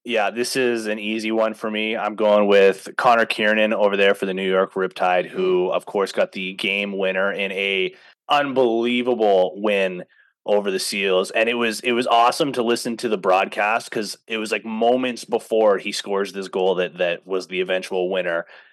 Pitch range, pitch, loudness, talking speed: 95-120 Hz, 110 Hz, -20 LUFS, 195 wpm